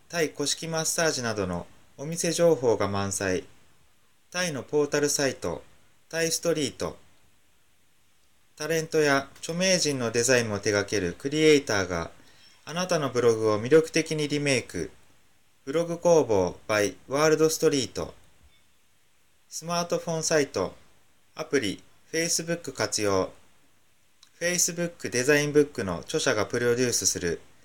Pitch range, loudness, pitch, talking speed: 105-160 Hz, -26 LUFS, 140 Hz, 270 characters per minute